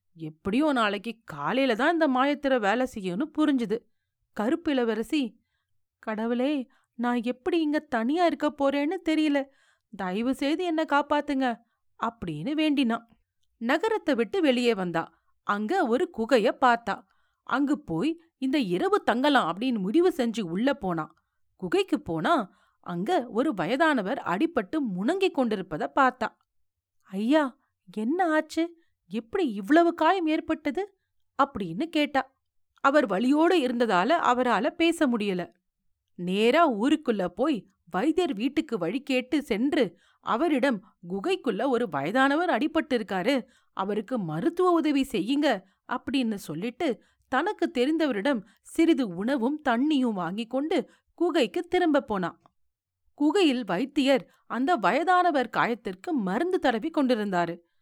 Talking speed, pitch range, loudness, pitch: 105 wpm, 220-310 Hz, -26 LUFS, 265 Hz